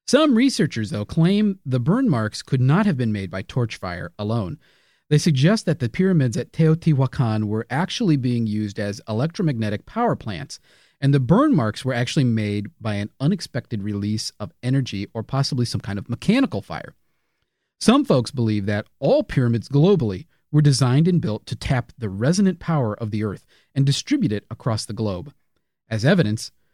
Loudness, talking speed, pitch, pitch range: -21 LUFS, 175 wpm, 130 Hz, 110-160 Hz